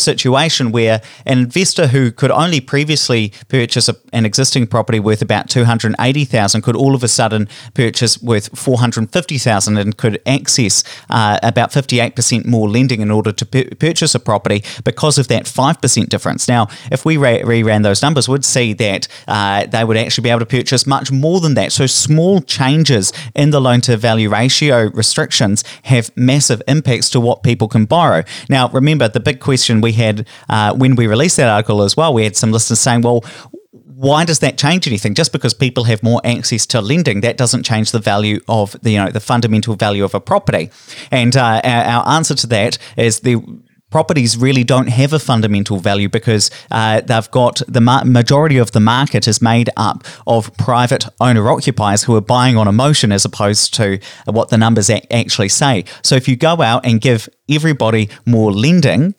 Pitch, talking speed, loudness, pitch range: 120 Hz, 190 wpm, -13 LUFS, 110-135 Hz